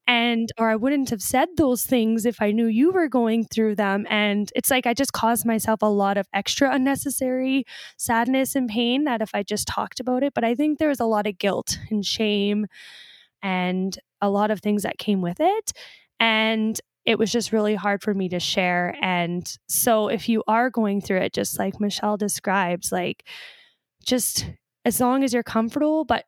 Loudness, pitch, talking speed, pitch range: -22 LUFS, 225 Hz, 200 wpm, 205-250 Hz